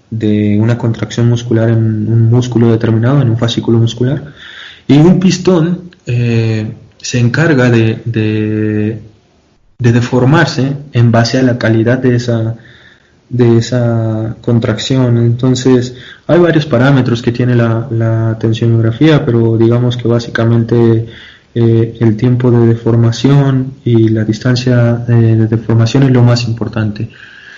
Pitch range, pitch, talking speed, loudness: 115-125 Hz, 115 Hz, 130 wpm, -11 LUFS